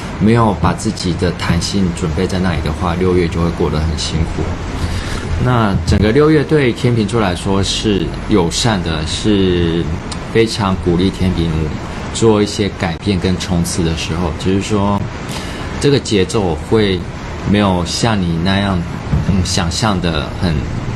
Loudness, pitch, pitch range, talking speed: -15 LUFS, 95 Hz, 85-105 Hz, 220 characters per minute